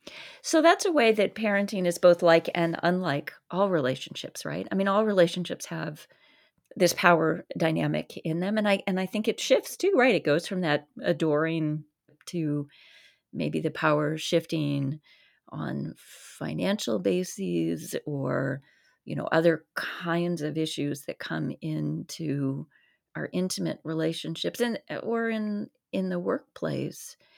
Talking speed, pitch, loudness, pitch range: 140 wpm, 170 Hz, -27 LUFS, 150-200 Hz